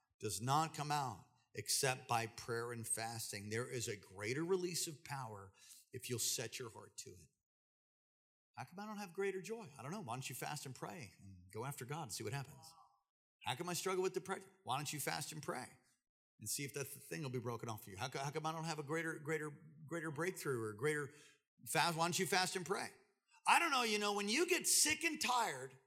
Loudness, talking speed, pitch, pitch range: -40 LUFS, 240 wpm, 150 Hz, 125-185 Hz